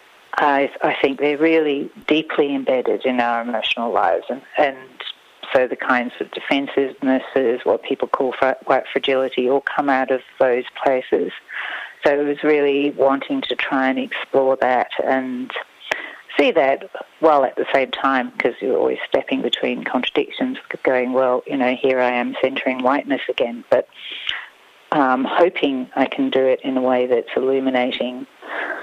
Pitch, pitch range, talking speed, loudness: 135 Hz, 130-150 Hz, 160 wpm, -19 LUFS